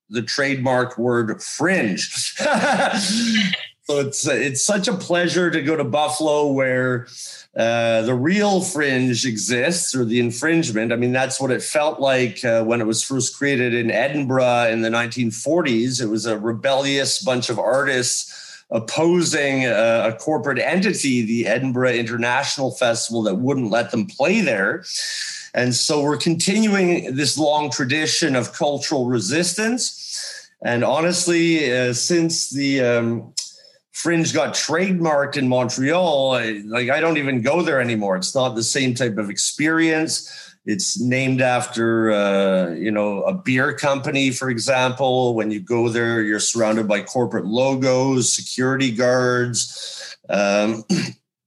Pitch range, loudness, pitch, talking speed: 120-150 Hz, -19 LUFS, 130 Hz, 140 wpm